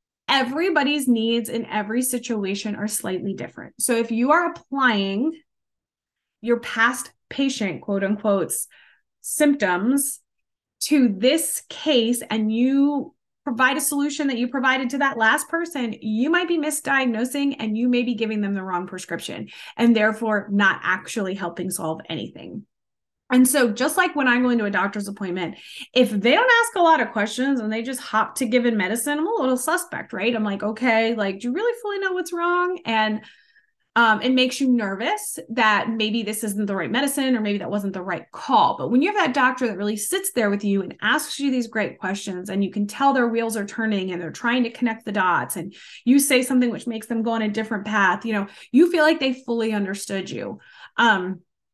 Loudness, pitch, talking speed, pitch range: -22 LUFS, 235 Hz, 200 wpm, 210-275 Hz